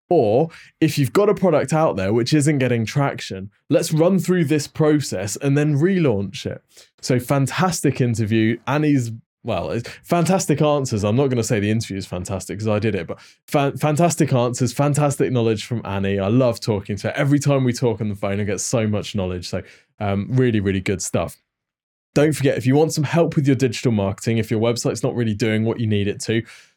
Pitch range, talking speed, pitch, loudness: 110-145 Hz, 210 wpm, 125 Hz, -20 LUFS